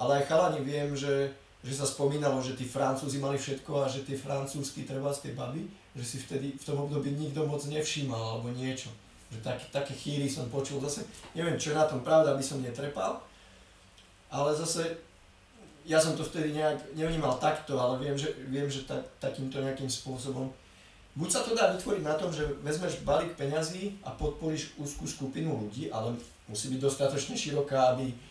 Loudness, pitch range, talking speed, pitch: -32 LUFS, 130-150 Hz, 185 wpm, 140 Hz